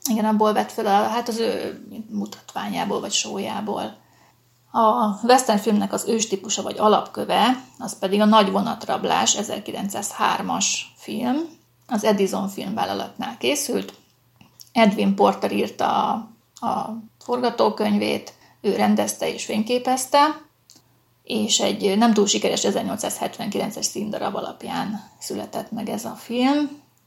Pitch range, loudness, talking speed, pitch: 210-240 Hz, -22 LUFS, 115 wpm, 220 Hz